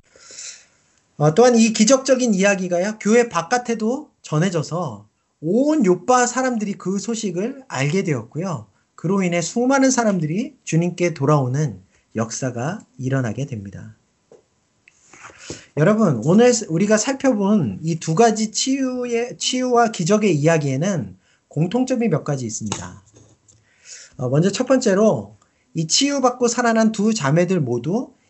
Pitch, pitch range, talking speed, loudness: 190 Hz, 145-235 Hz, 275 characters per minute, -19 LUFS